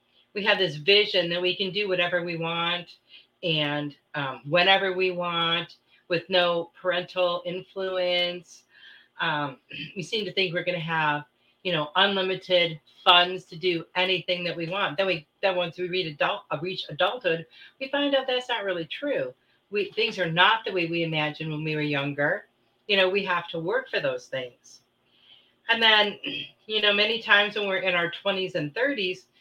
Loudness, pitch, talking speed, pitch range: -25 LUFS, 180 Hz, 185 wpm, 165-195 Hz